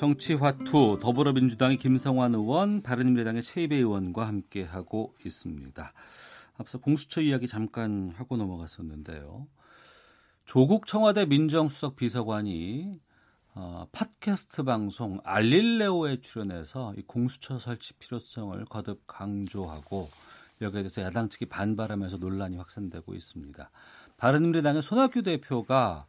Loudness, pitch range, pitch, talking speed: -28 LUFS, 100-140 Hz, 120 Hz, 315 characters per minute